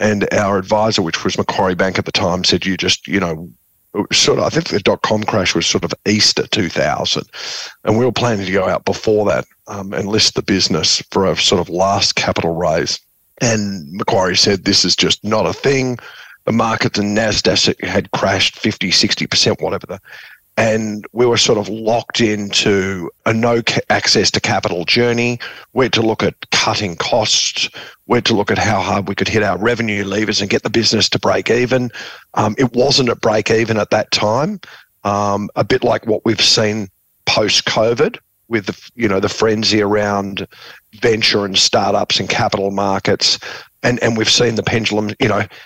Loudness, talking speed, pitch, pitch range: -15 LUFS, 195 wpm, 105 Hz, 100-115 Hz